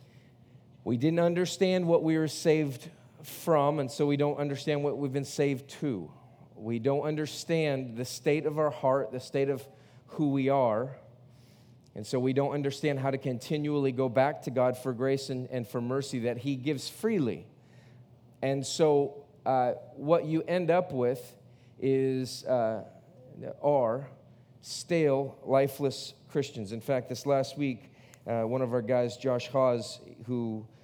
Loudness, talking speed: -30 LUFS, 160 wpm